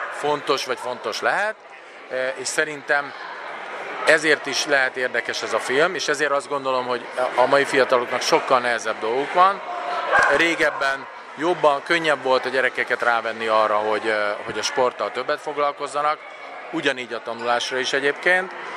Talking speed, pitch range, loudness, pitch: 140 wpm, 120-150 Hz, -21 LUFS, 135 Hz